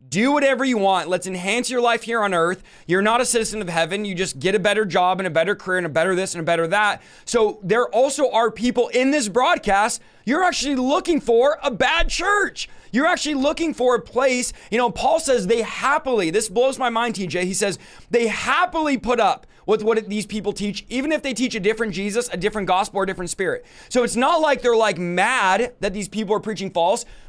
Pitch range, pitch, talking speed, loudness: 195-260 Hz, 230 Hz, 230 wpm, -20 LUFS